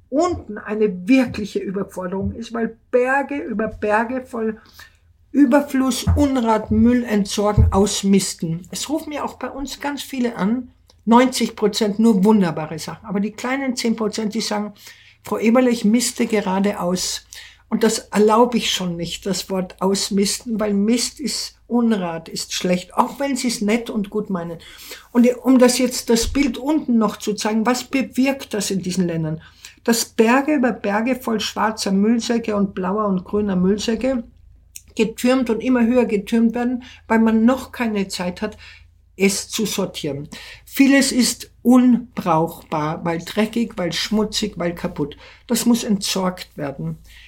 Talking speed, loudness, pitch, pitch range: 150 wpm, -19 LUFS, 220 Hz, 195-245 Hz